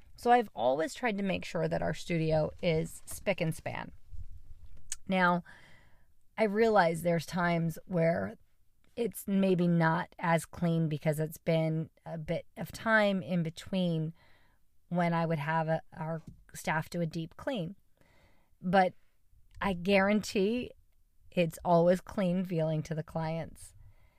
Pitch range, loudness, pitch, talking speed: 155-185 Hz, -31 LUFS, 165 Hz, 135 wpm